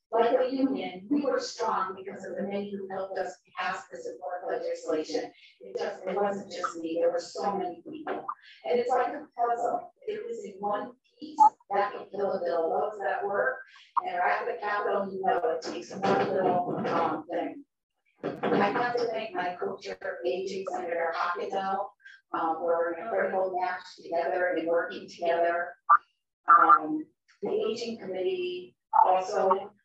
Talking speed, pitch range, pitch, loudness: 165 wpm, 180-275 Hz, 200 Hz, -29 LUFS